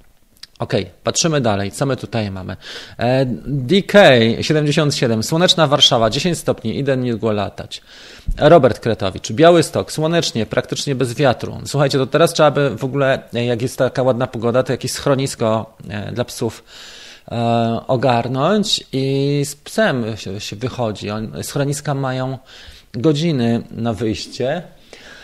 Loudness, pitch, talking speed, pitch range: -17 LUFS, 130 Hz, 125 wpm, 115-145 Hz